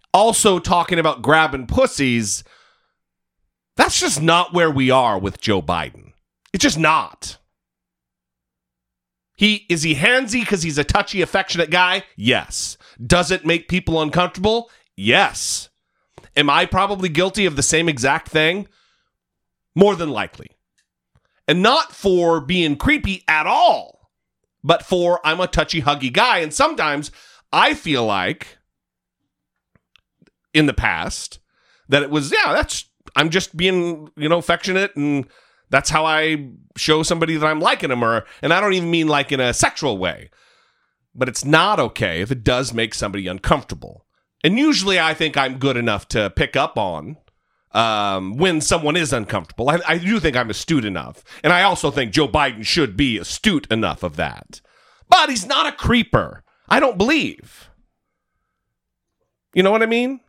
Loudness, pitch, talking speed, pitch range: -18 LUFS, 155 Hz, 155 wpm, 125-180 Hz